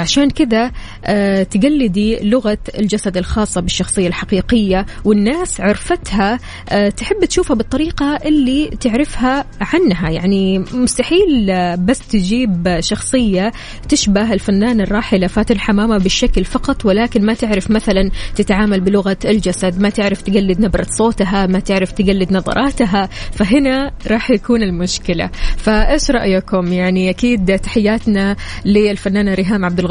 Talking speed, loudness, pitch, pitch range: 115 wpm, -15 LUFS, 210 Hz, 195-245 Hz